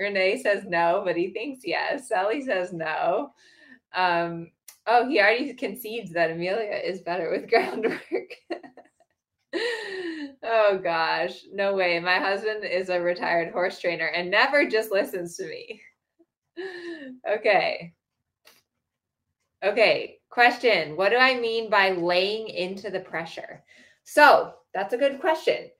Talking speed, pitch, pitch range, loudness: 130 wpm, 205 Hz, 180-290 Hz, -24 LUFS